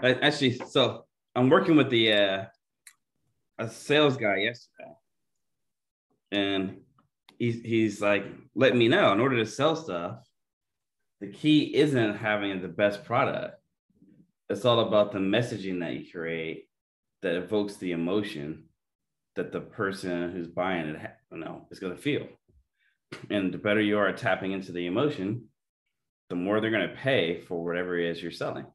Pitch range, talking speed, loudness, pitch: 90-115 Hz, 160 wpm, -27 LUFS, 100 Hz